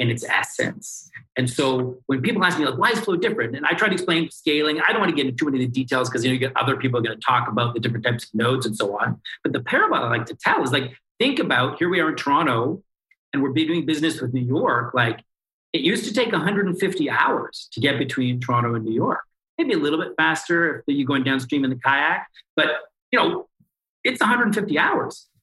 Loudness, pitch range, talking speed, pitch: -21 LUFS, 125-160 Hz, 250 wpm, 135 Hz